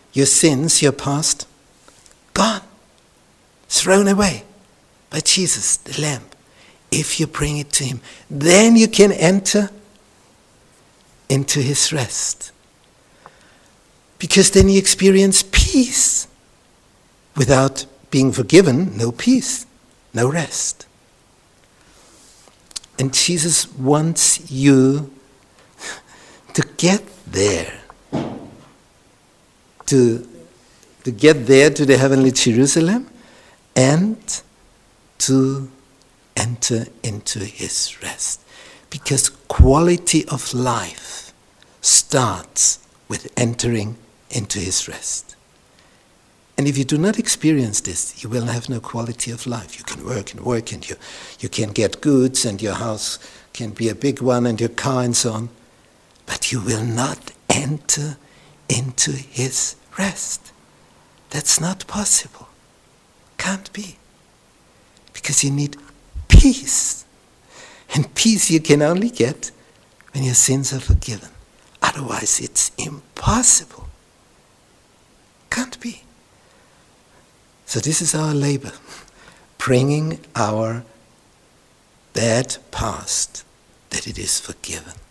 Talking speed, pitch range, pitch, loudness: 105 wpm, 120-165 Hz, 135 Hz, -17 LUFS